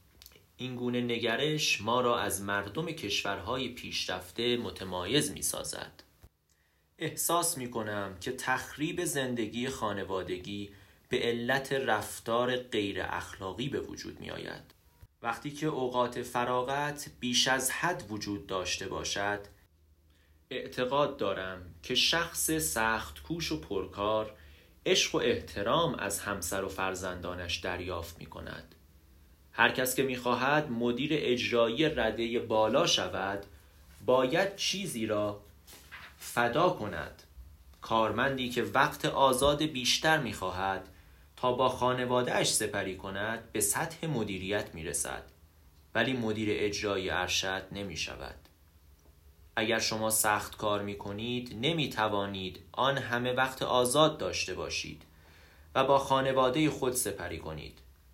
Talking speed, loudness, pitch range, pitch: 115 wpm, -31 LUFS, 90-125 Hz, 105 Hz